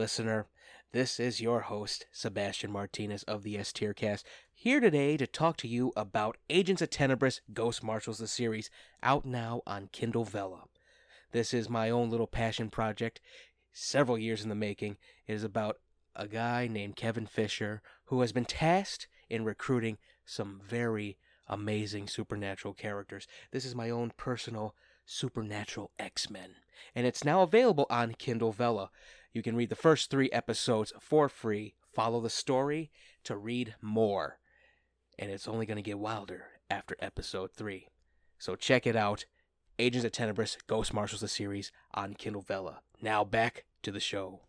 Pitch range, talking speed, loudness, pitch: 105-120 Hz, 165 wpm, -33 LUFS, 115 Hz